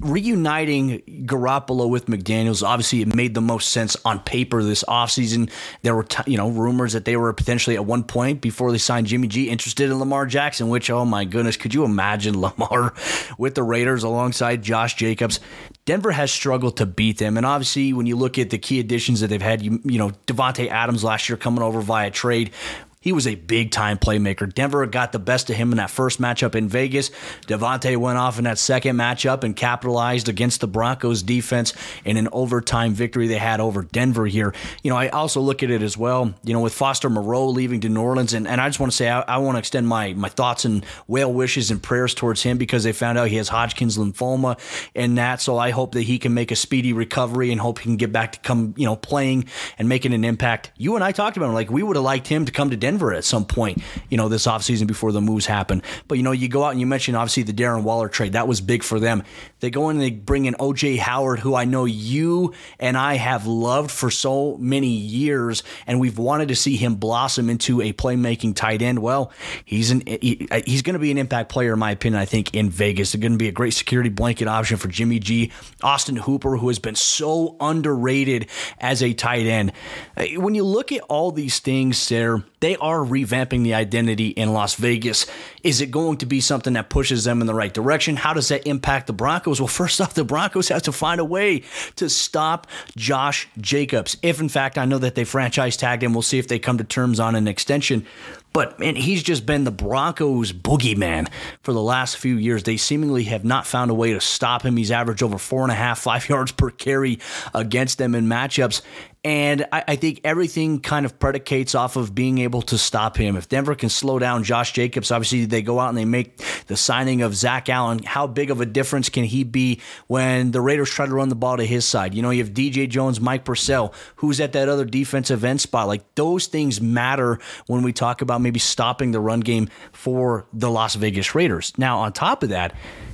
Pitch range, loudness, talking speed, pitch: 115-135 Hz, -21 LUFS, 230 wpm, 125 Hz